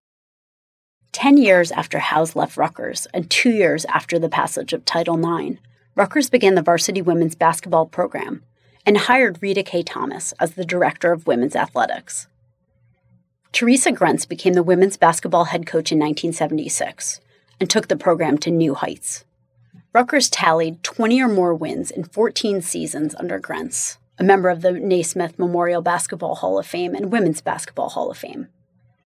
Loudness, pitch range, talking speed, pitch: -19 LUFS, 160-195 Hz, 160 wpm, 175 Hz